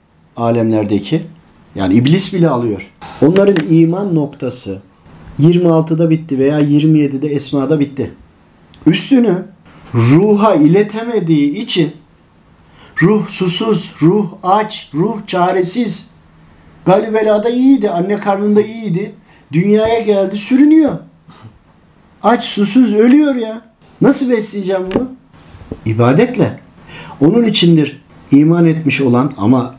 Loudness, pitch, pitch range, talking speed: -12 LUFS, 175 Hz, 145-210 Hz, 95 wpm